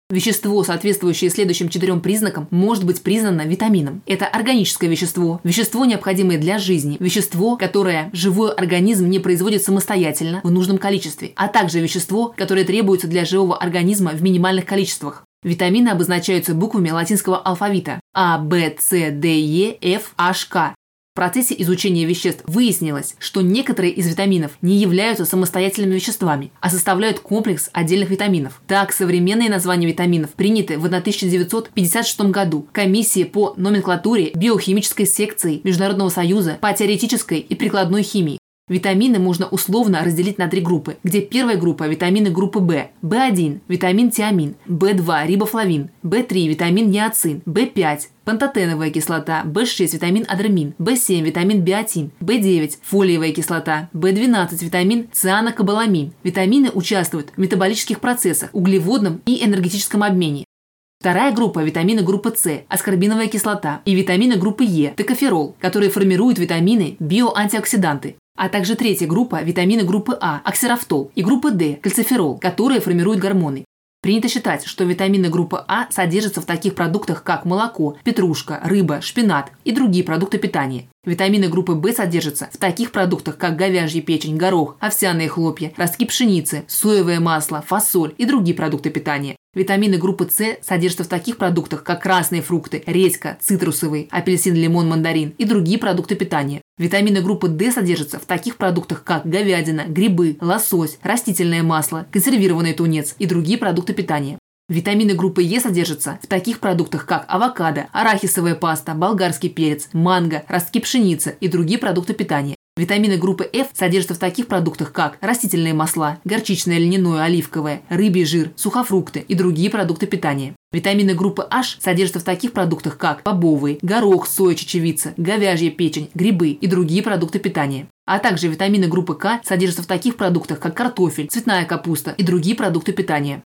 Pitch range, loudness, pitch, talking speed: 170-205 Hz, -18 LUFS, 185 Hz, 145 wpm